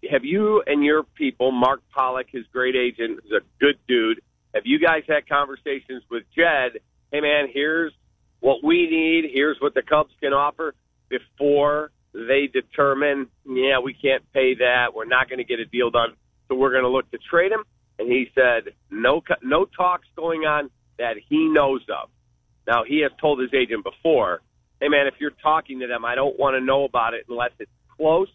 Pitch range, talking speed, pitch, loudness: 125-155 Hz, 195 wpm, 140 Hz, -21 LUFS